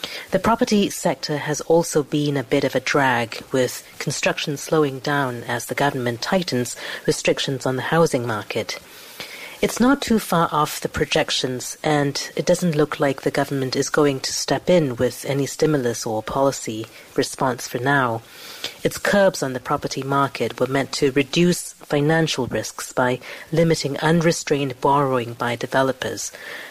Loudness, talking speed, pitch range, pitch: -21 LUFS, 155 wpm, 130-155 Hz, 140 Hz